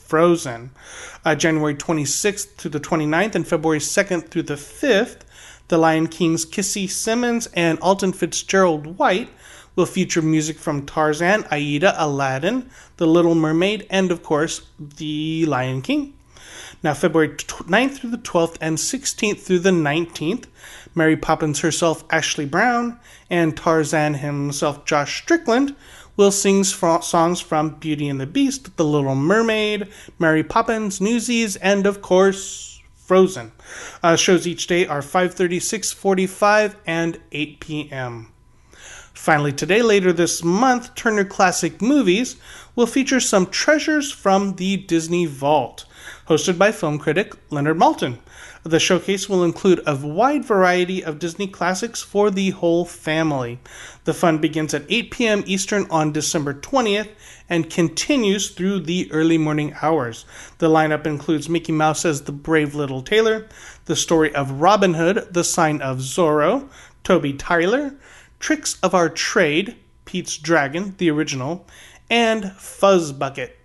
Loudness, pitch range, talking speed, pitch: -19 LUFS, 155-195 Hz, 140 wpm, 170 Hz